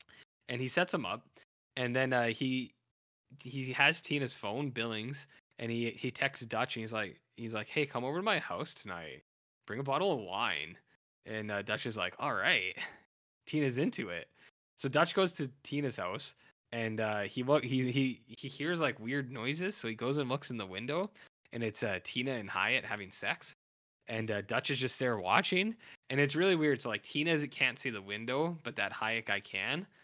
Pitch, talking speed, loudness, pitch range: 130 Hz, 200 wpm, -34 LUFS, 115-145 Hz